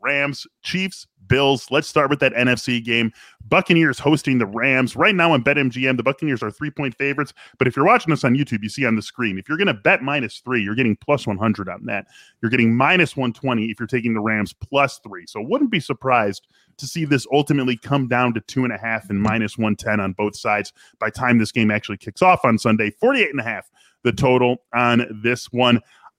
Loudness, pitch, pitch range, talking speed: -19 LUFS, 125 Hz, 110-140 Hz, 220 wpm